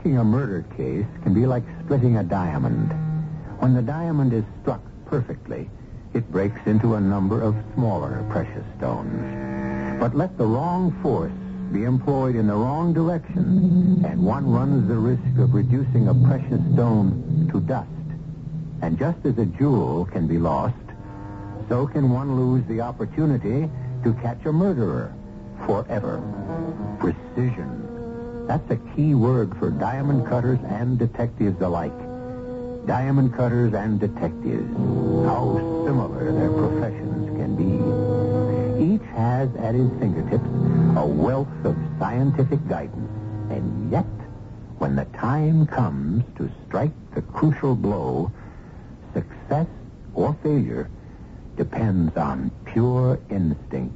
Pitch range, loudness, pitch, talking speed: 110-145 Hz, -23 LUFS, 125 Hz, 130 wpm